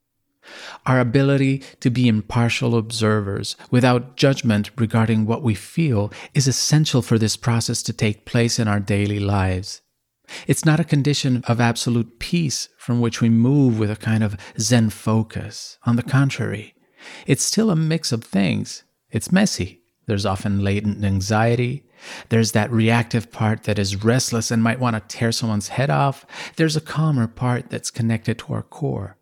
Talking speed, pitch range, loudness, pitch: 165 wpm, 105-130 Hz, -20 LUFS, 115 Hz